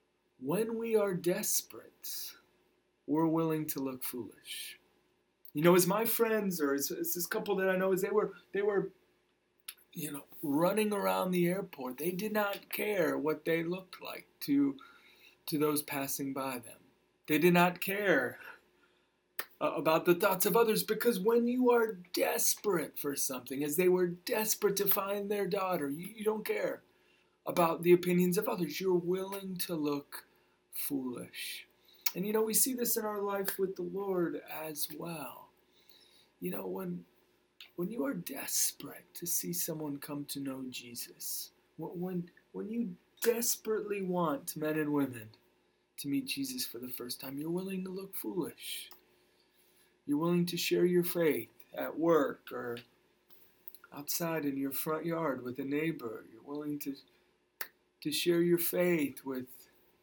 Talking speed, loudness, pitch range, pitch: 160 wpm, -33 LUFS, 145-200 Hz, 175 Hz